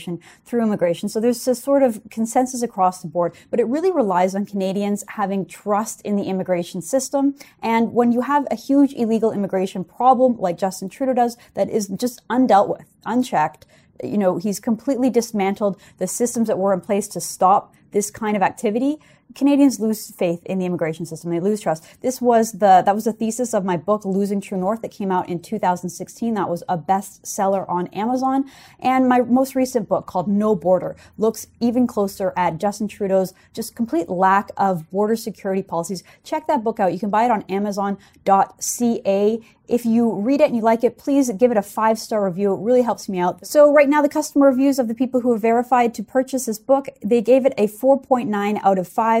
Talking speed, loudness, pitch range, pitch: 205 wpm, -20 LUFS, 195-245 Hz, 215 Hz